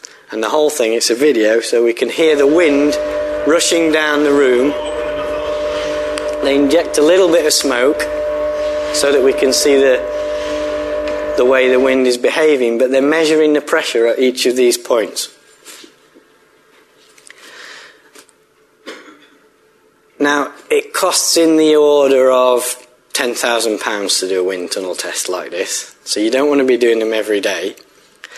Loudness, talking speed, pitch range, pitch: -14 LUFS, 150 wpm, 130-160 Hz, 150 Hz